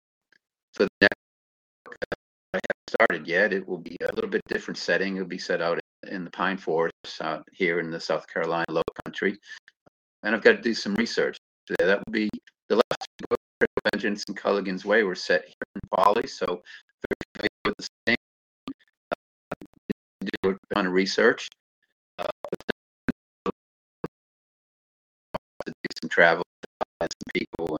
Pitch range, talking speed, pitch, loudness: 70-95 Hz, 160 wpm, 90 Hz, -26 LUFS